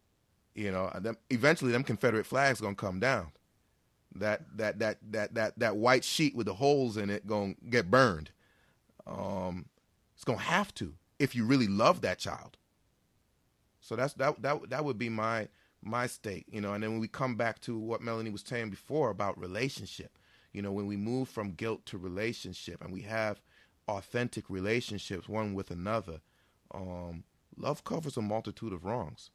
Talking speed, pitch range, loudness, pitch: 175 wpm, 100-120 Hz, -33 LUFS, 110 Hz